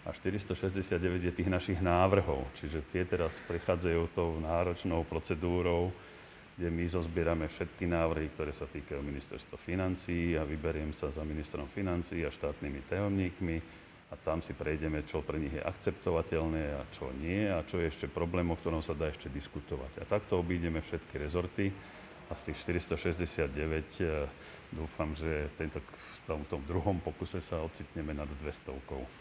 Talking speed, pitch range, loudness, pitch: 155 wpm, 80-90 Hz, -36 LUFS, 85 Hz